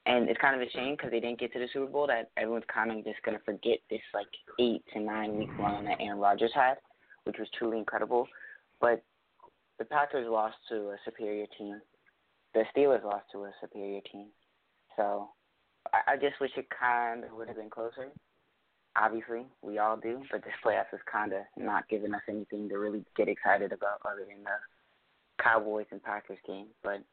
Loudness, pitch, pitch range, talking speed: -32 LUFS, 110 Hz, 105-120 Hz, 200 wpm